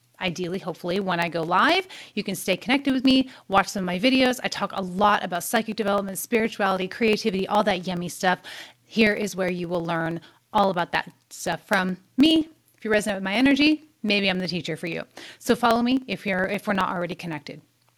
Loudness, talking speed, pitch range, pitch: -24 LUFS, 215 wpm, 180-225 Hz, 195 Hz